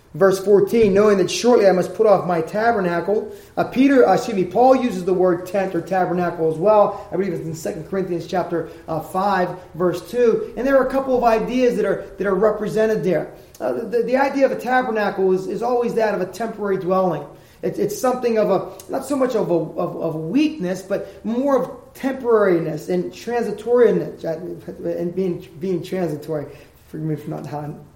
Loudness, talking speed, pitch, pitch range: -20 LUFS, 200 wpm, 195 Hz, 175-230 Hz